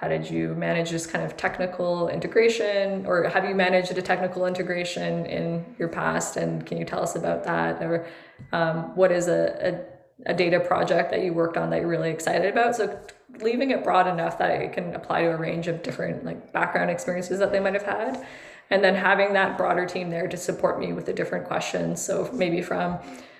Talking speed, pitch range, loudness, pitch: 215 wpm, 165-190 Hz, -25 LUFS, 180 Hz